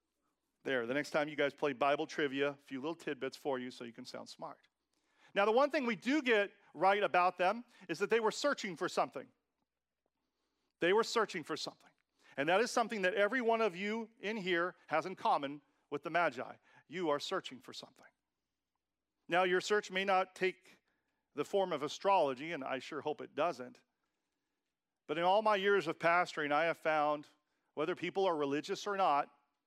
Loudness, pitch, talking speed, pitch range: -35 LUFS, 180 Hz, 195 wpm, 150-205 Hz